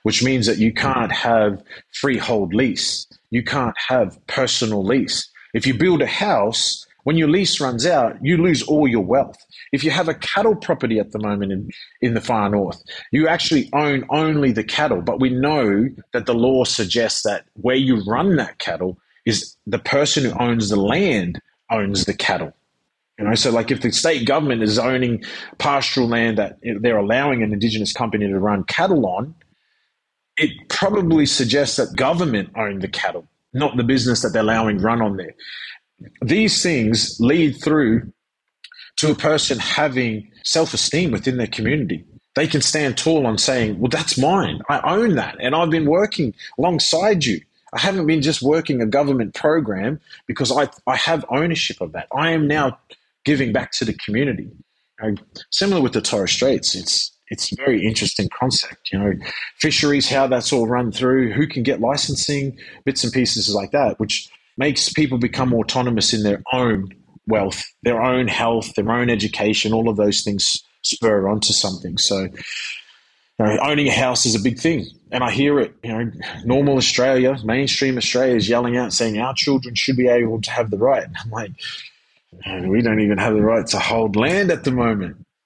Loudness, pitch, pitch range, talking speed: -19 LUFS, 125 Hz, 110-140 Hz, 185 wpm